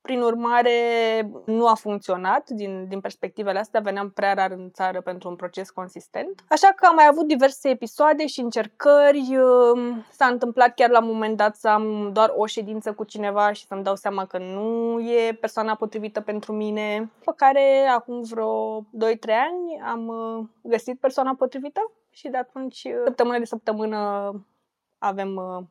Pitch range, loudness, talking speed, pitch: 205-250 Hz, -22 LUFS, 165 wpm, 225 Hz